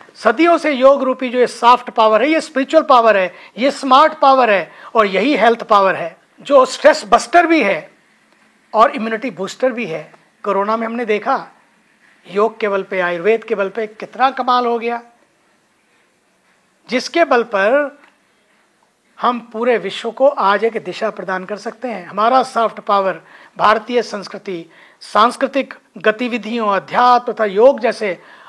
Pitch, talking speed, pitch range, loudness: 235 Hz, 155 wpm, 210-260 Hz, -15 LUFS